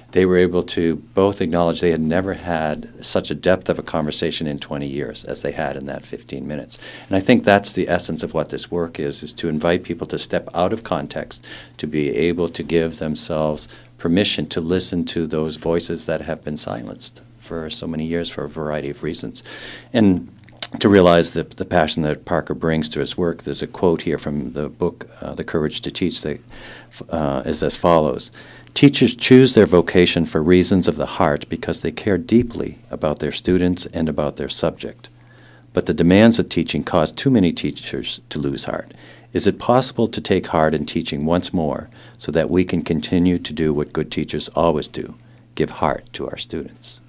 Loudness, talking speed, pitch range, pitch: -20 LUFS, 205 wpm, 75-90 Hz, 85 Hz